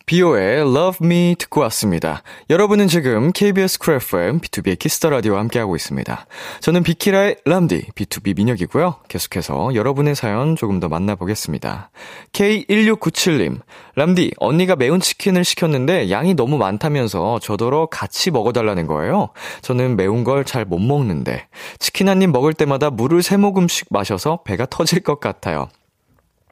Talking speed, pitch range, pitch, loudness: 345 characters per minute, 115-180 Hz, 155 Hz, -17 LUFS